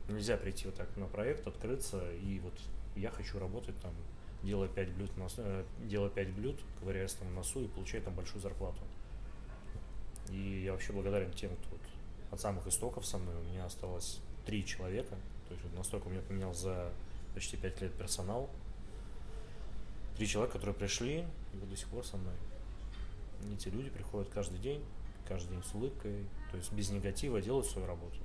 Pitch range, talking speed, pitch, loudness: 95-105 Hz, 185 wpm, 100 Hz, -42 LUFS